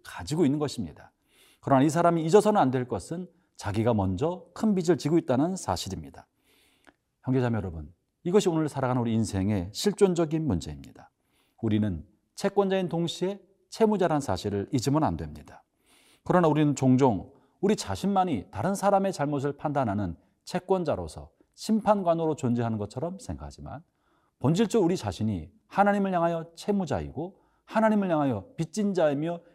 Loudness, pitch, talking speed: -27 LUFS, 155 Hz, 365 characters per minute